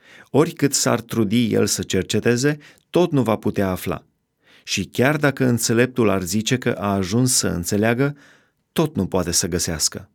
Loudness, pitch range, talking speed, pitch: -20 LUFS, 95-130 Hz, 160 wpm, 115 Hz